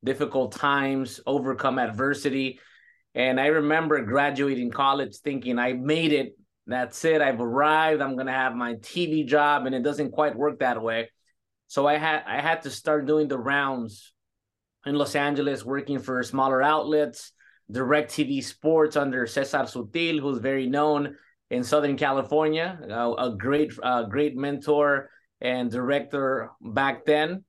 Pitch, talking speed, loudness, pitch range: 140 Hz, 150 wpm, -25 LUFS, 130-150 Hz